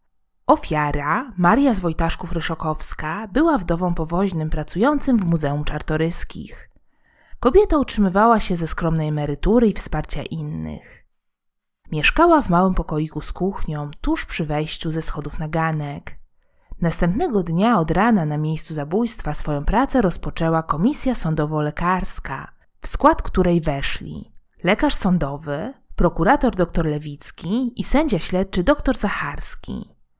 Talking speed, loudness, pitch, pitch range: 115 wpm, -20 LUFS, 170 Hz, 150-215 Hz